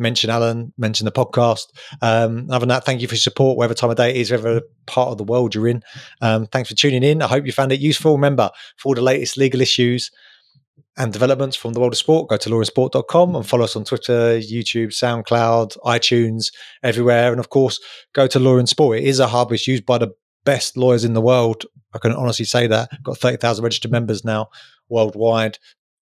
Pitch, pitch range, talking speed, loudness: 120 Hz, 115-130 Hz, 225 wpm, -18 LUFS